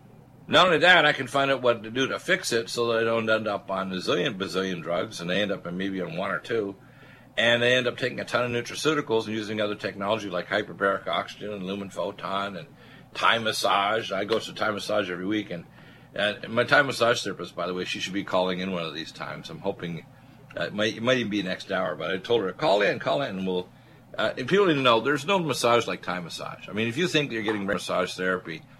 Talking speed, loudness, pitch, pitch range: 260 wpm, -25 LUFS, 105 Hz, 95-120 Hz